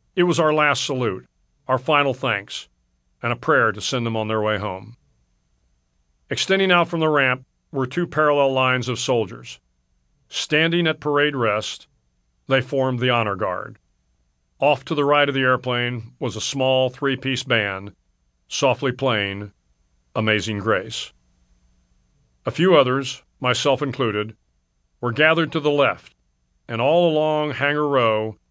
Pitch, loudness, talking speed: 125 Hz, -21 LUFS, 145 wpm